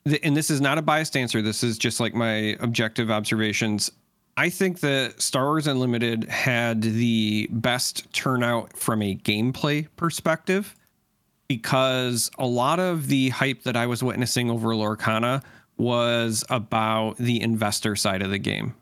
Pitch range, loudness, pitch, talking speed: 110-135 Hz, -24 LUFS, 120 Hz, 155 wpm